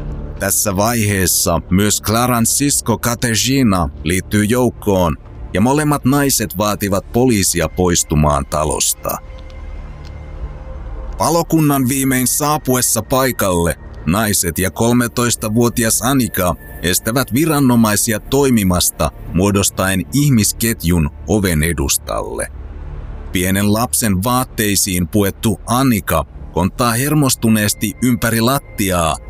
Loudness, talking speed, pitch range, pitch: -15 LUFS, 80 wpm, 85-120 Hz, 105 Hz